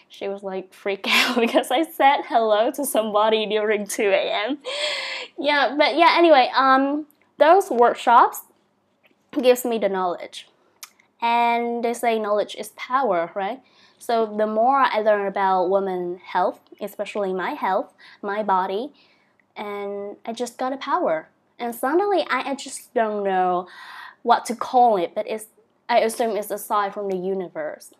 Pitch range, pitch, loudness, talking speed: 205-275 Hz, 235 Hz, -21 LUFS, 155 wpm